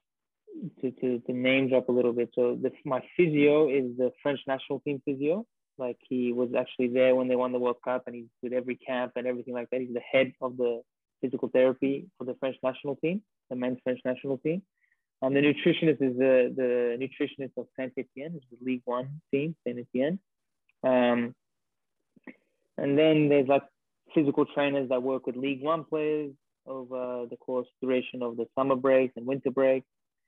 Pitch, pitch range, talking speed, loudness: 130 Hz, 125-140 Hz, 190 wpm, -28 LUFS